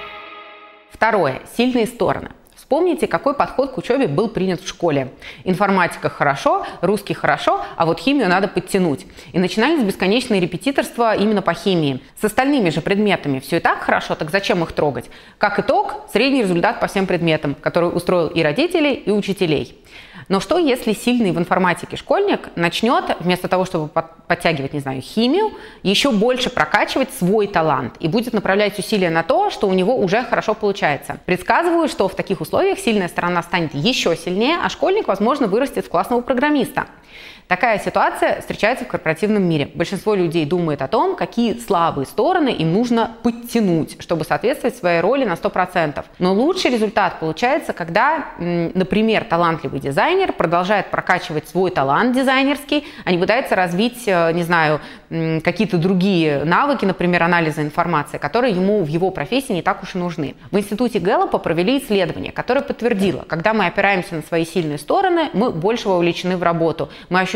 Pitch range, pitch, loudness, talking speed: 170-230 Hz, 190 Hz, -18 LUFS, 160 wpm